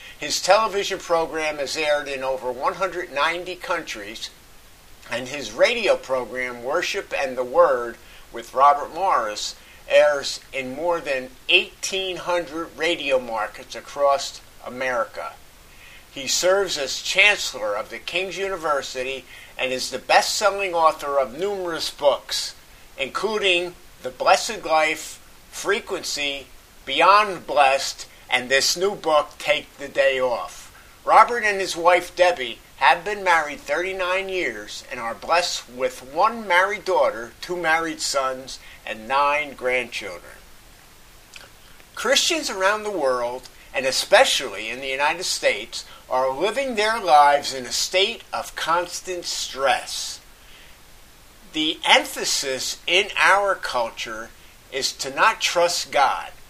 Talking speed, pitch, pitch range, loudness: 120 wpm, 170 Hz, 135-195 Hz, -21 LUFS